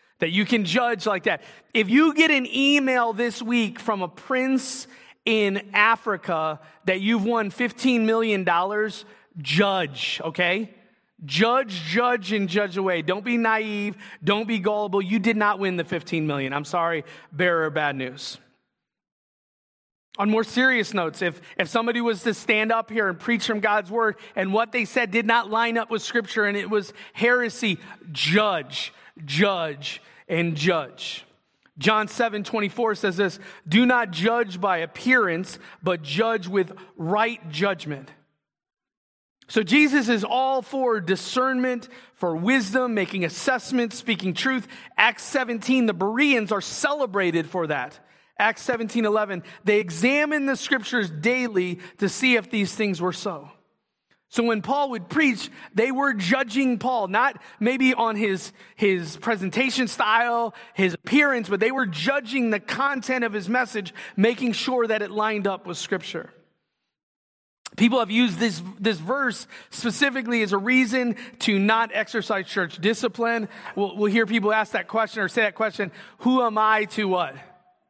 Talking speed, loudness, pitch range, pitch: 155 wpm, -23 LUFS, 190-240 Hz, 215 Hz